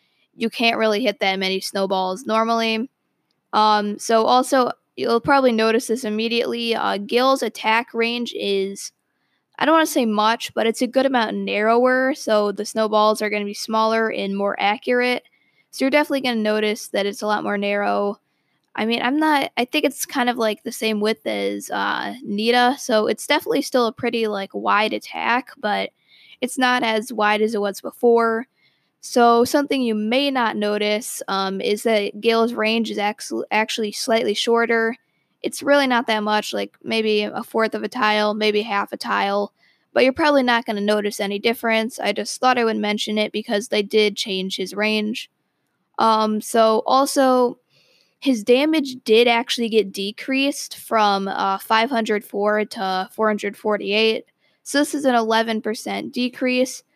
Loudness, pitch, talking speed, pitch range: -20 LUFS, 225 Hz, 170 wpm, 210-245 Hz